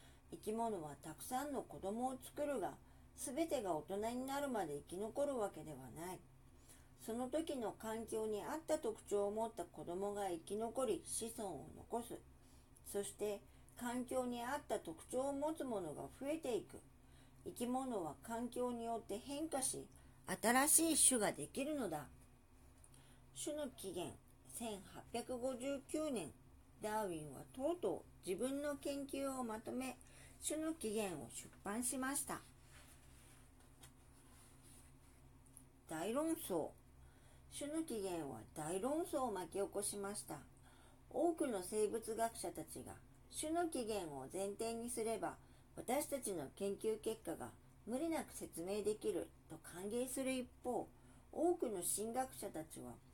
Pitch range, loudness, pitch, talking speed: 195-280 Hz, -43 LUFS, 230 Hz, 245 characters per minute